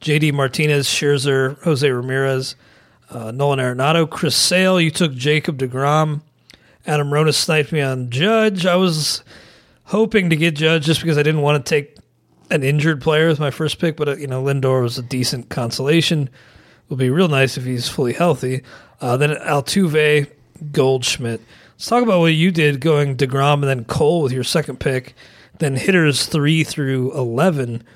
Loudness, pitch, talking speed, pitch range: -17 LUFS, 145 Hz, 175 wpm, 130-160 Hz